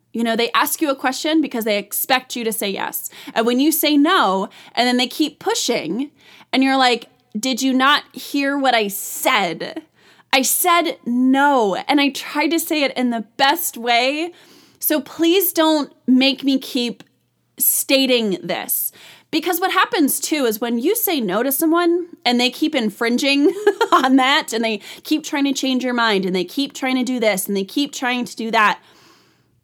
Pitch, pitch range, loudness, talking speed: 270 Hz, 240-310 Hz, -18 LUFS, 190 wpm